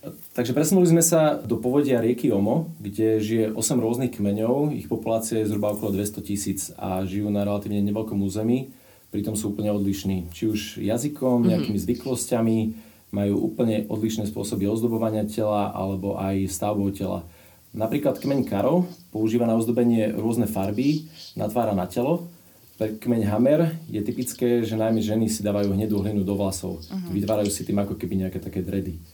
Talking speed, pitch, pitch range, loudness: 160 wpm, 110 Hz, 100-120 Hz, -24 LUFS